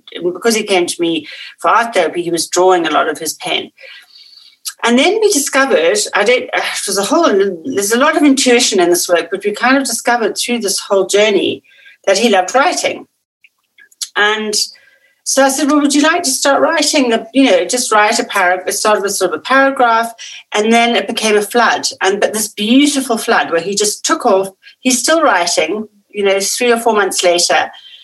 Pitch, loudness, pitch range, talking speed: 230 Hz, -13 LUFS, 195-275 Hz, 210 wpm